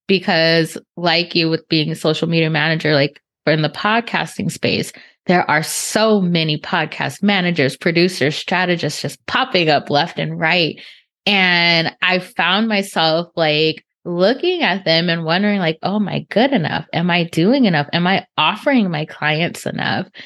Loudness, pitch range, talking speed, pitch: -16 LUFS, 155-190 Hz, 165 wpm, 170 Hz